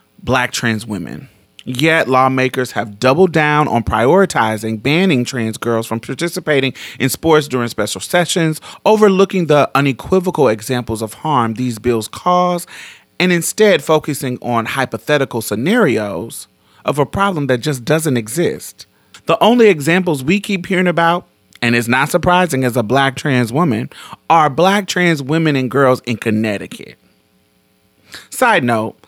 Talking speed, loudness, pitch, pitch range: 140 wpm, -15 LUFS, 135 Hz, 120-170 Hz